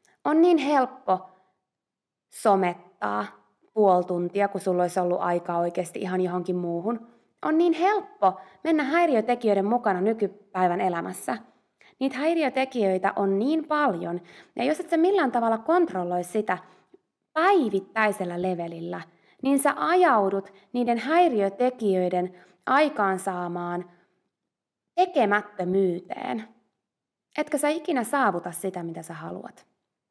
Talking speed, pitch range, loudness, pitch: 105 wpm, 180-275 Hz, -25 LUFS, 200 Hz